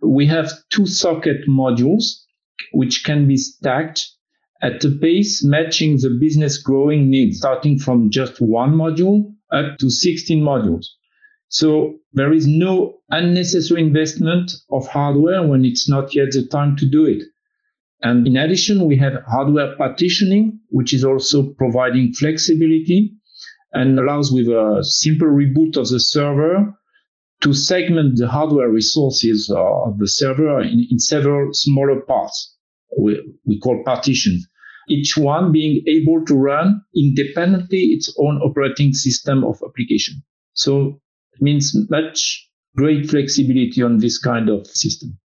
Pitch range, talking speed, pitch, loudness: 135-165 Hz, 140 wpm, 145 Hz, -16 LUFS